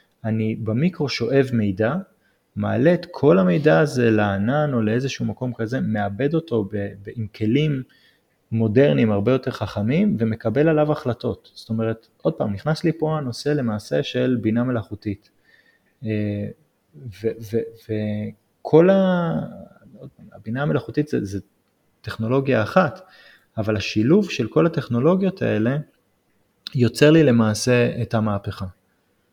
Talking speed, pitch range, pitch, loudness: 120 wpm, 110-145 Hz, 115 Hz, -21 LUFS